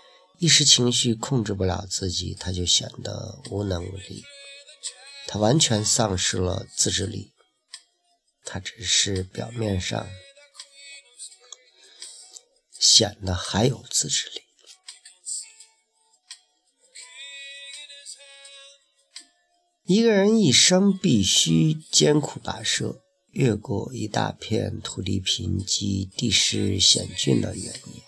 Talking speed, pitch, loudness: 145 characters per minute, 145 Hz, -21 LUFS